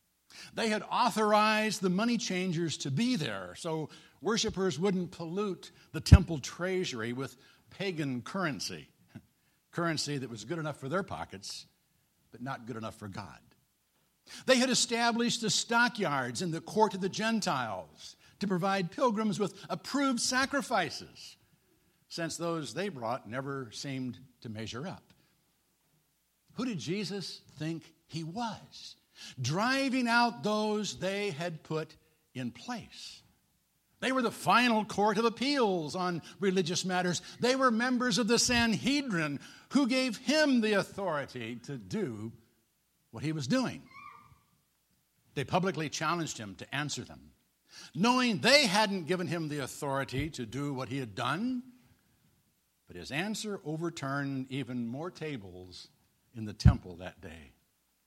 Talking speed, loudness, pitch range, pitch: 135 wpm, -31 LUFS, 135-215 Hz, 170 Hz